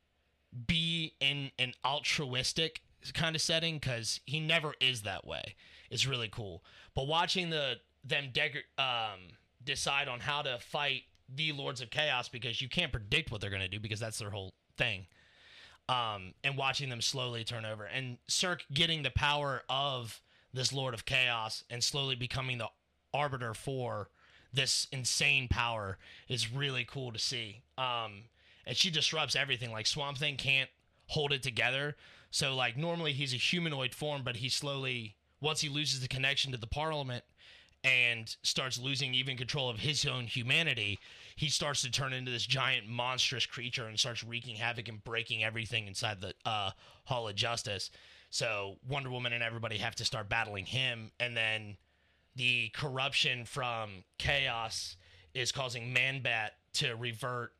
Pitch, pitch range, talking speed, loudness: 125 Hz, 115-140 Hz, 165 wpm, -33 LUFS